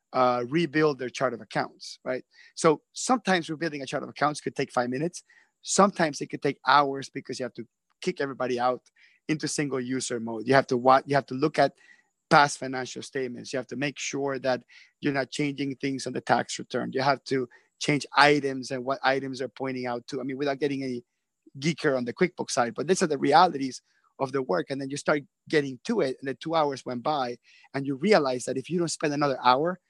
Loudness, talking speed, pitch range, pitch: -27 LUFS, 225 wpm, 130-150 Hz, 135 Hz